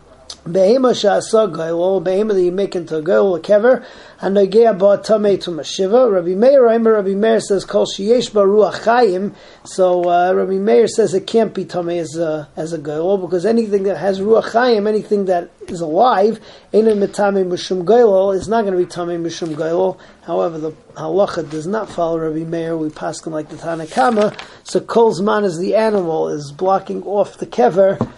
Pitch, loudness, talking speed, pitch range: 195 Hz, -16 LUFS, 175 wpm, 175-215 Hz